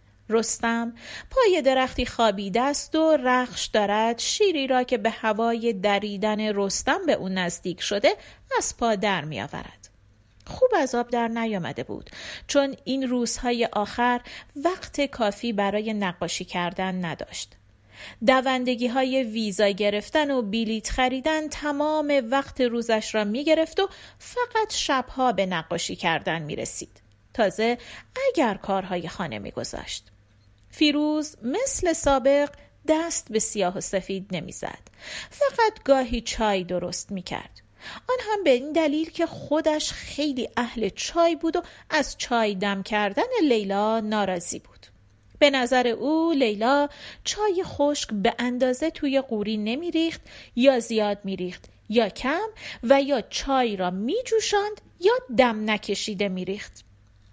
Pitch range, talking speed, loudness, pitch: 200-290 Hz, 130 wpm, -24 LUFS, 235 Hz